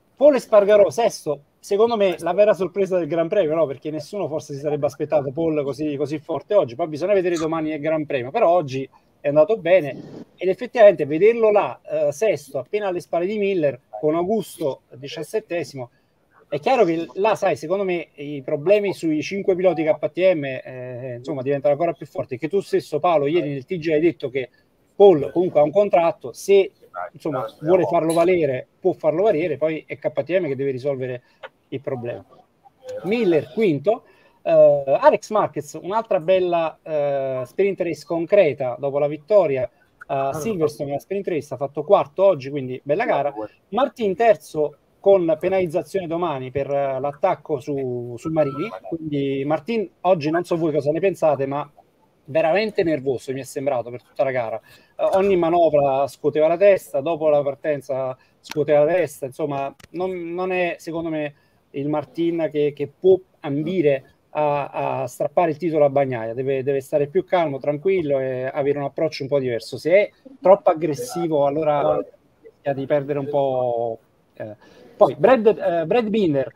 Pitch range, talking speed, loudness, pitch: 140-190 Hz, 170 wpm, -21 LUFS, 155 Hz